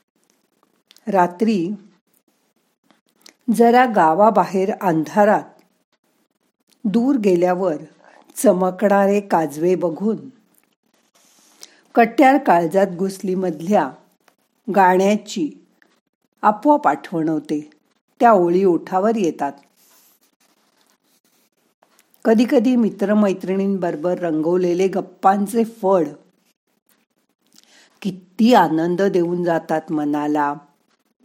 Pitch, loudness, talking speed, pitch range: 195 Hz, -18 LUFS, 60 wpm, 175-225 Hz